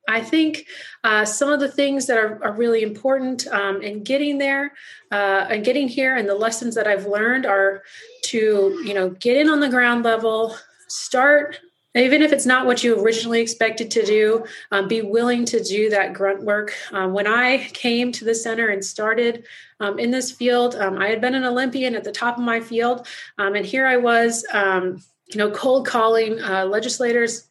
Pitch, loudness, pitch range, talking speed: 230 Hz, -19 LUFS, 210-255 Hz, 200 wpm